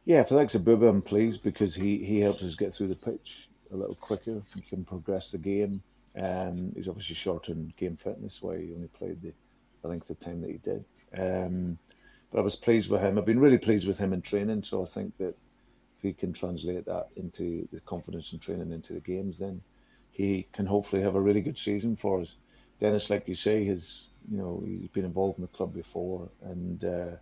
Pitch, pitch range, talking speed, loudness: 95 Hz, 90-105 Hz, 230 wpm, -30 LUFS